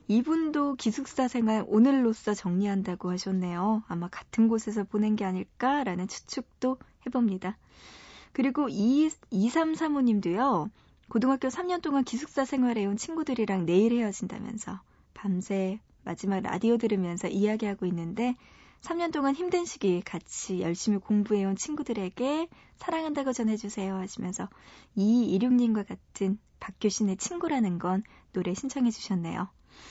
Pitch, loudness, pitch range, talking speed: 220 Hz, -29 LUFS, 195-265 Hz, 325 characters per minute